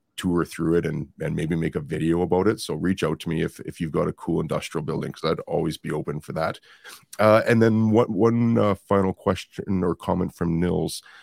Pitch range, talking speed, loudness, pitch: 85-110 Hz, 235 wpm, -24 LUFS, 95 Hz